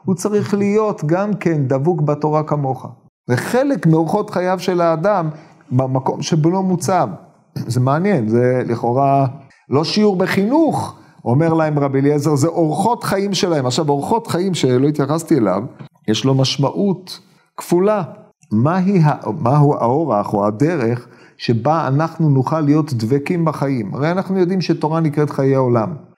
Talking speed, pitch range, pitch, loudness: 140 wpm, 135-185 Hz, 155 Hz, -17 LUFS